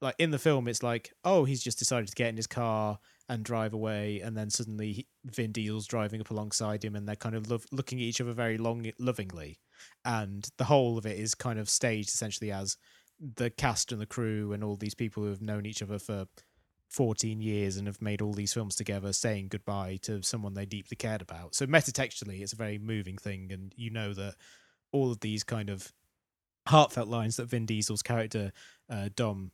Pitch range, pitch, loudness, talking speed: 105-120 Hz, 110 Hz, -32 LUFS, 215 wpm